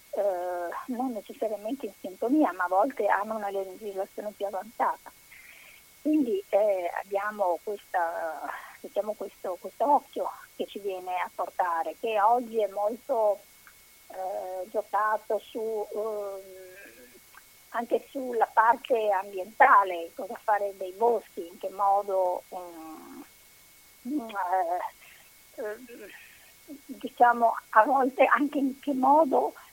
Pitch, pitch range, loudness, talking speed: 210 Hz, 195-255 Hz, -28 LUFS, 110 wpm